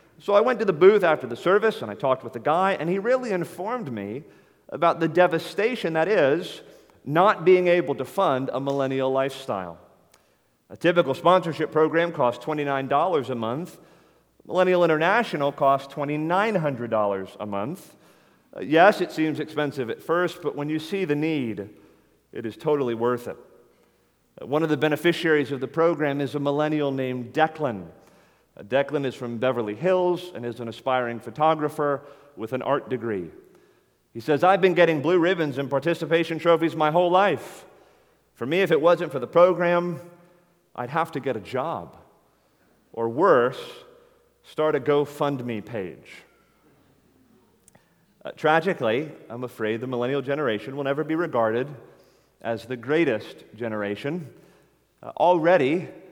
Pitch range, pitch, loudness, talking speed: 125-175 Hz, 150 Hz, -23 LUFS, 150 wpm